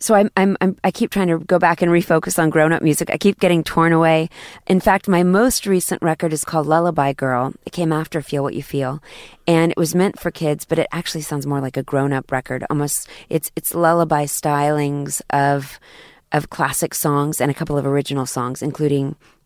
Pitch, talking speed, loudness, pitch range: 160 Hz, 215 wpm, -18 LUFS, 140-170 Hz